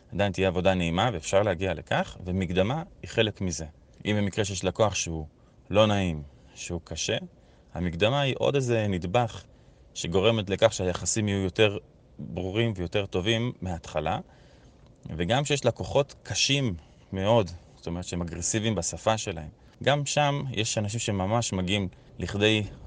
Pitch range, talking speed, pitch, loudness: 90-115 Hz, 135 wpm, 100 Hz, -27 LUFS